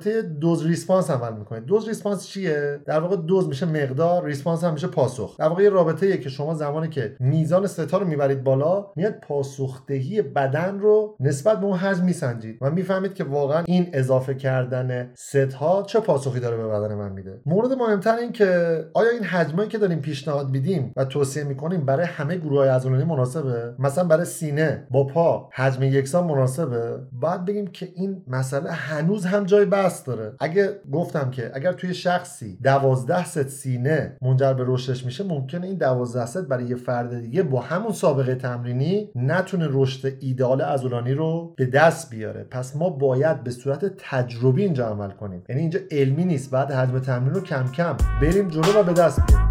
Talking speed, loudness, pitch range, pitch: 180 wpm, -23 LUFS, 130-180 Hz, 150 Hz